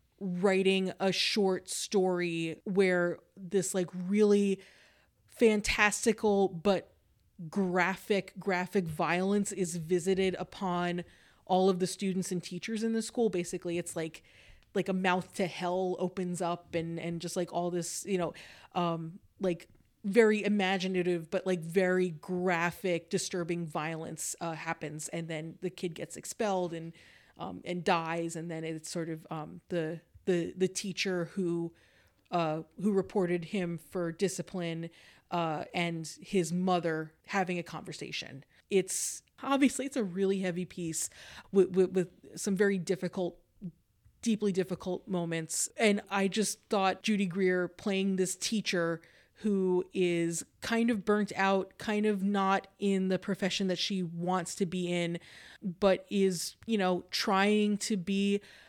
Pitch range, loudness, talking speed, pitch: 170-195 Hz, -32 LUFS, 140 wpm, 185 Hz